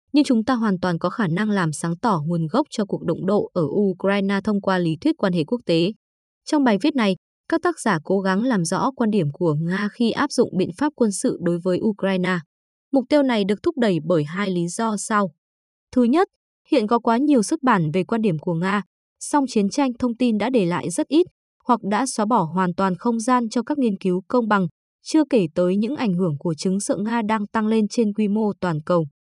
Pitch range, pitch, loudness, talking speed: 185-245 Hz, 210 Hz, -21 LUFS, 240 wpm